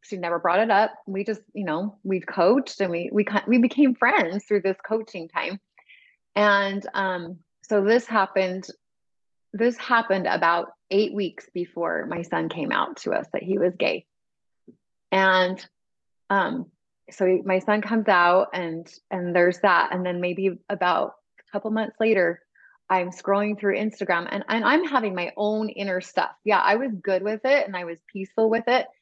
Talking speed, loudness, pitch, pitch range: 180 wpm, -23 LUFS, 200 Hz, 185-220 Hz